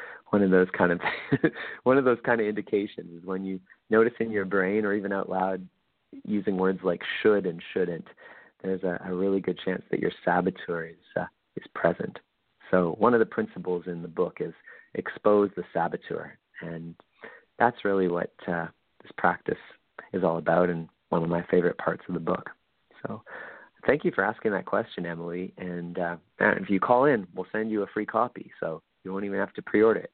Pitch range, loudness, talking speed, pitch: 90-105 Hz, -27 LUFS, 200 wpm, 95 Hz